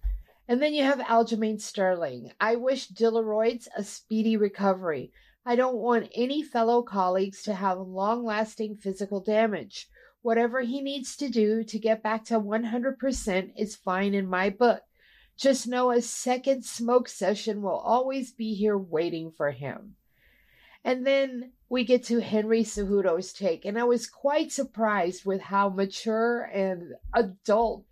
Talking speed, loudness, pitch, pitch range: 150 wpm, -27 LUFS, 220 Hz, 200-245 Hz